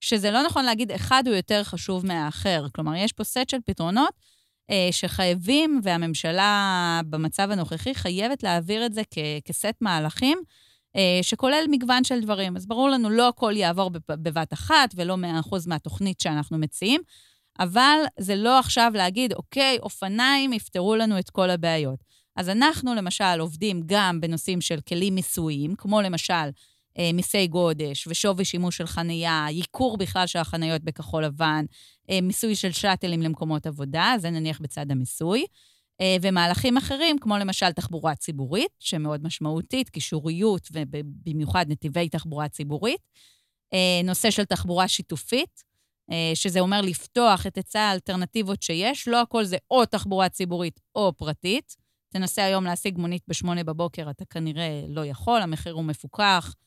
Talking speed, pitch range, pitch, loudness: 140 wpm, 165-215 Hz, 185 Hz, -24 LUFS